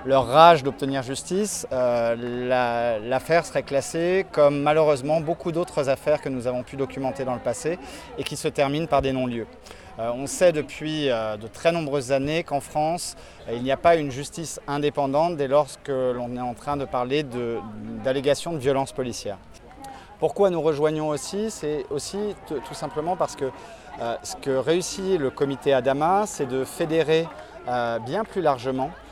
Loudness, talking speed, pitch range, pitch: -24 LUFS, 175 wpm, 130-160 Hz, 140 Hz